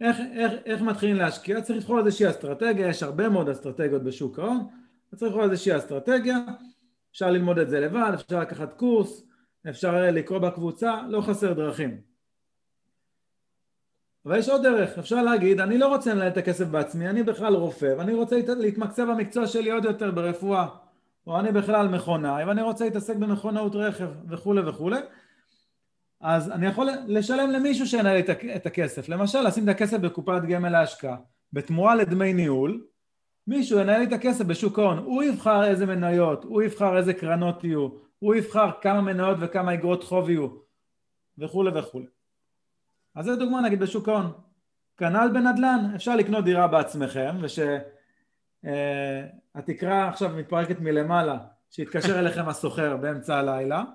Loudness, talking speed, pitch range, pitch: -25 LUFS, 150 wpm, 170-220 Hz, 190 Hz